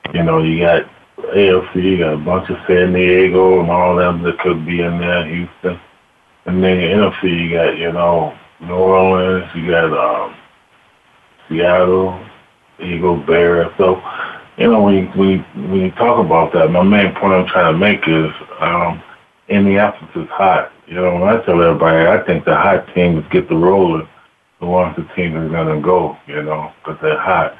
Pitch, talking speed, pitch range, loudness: 90 Hz, 195 wpm, 85-95 Hz, -14 LUFS